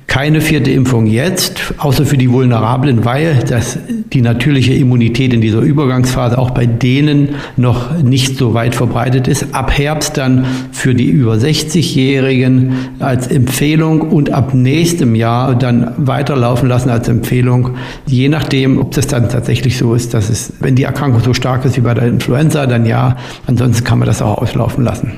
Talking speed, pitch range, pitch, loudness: 170 wpm, 120-140 Hz, 130 Hz, -12 LUFS